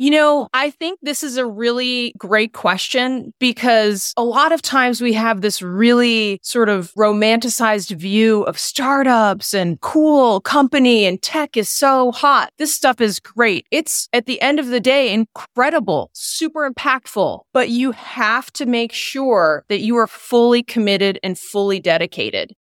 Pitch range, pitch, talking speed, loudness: 215-270 Hz, 240 Hz, 160 wpm, -16 LUFS